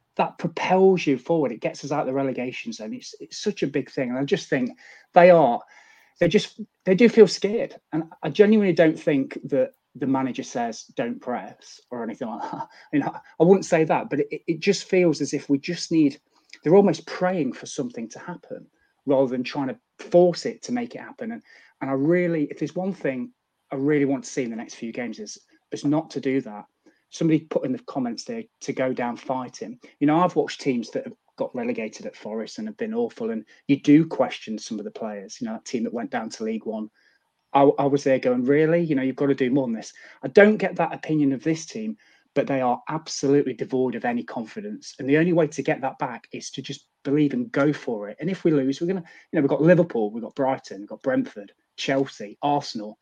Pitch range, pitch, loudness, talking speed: 140-220 Hz, 160 Hz, -23 LUFS, 240 wpm